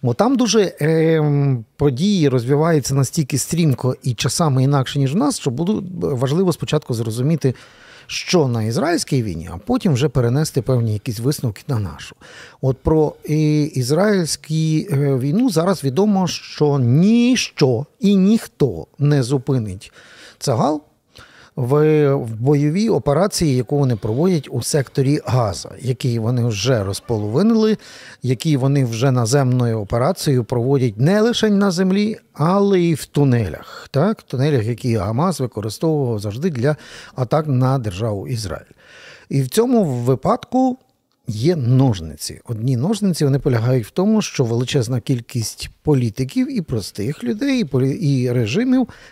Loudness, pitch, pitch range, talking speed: -18 LUFS, 140 Hz, 125-170 Hz, 130 wpm